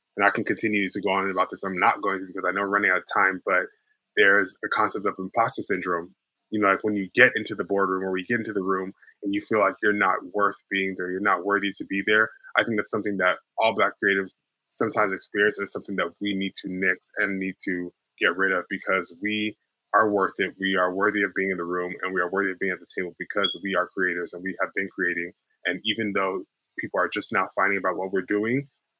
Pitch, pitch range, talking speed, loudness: 95 Hz, 95-105 Hz, 260 wpm, -24 LUFS